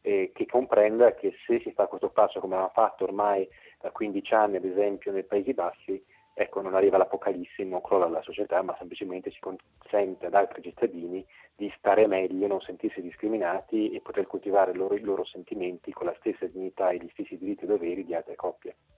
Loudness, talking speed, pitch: -28 LUFS, 190 wpm, 105 Hz